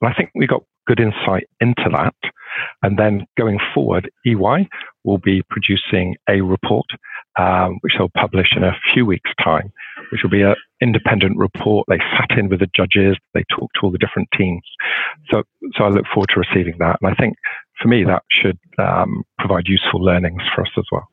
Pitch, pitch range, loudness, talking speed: 100 Hz, 95-105 Hz, -17 LUFS, 200 wpm